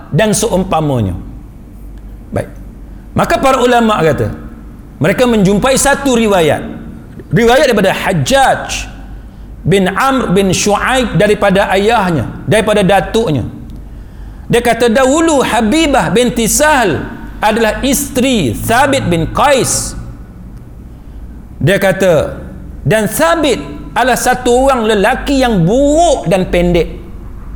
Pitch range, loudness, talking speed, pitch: 155-250 Hz, -11 LUFS, 100 wpm, 210 Hz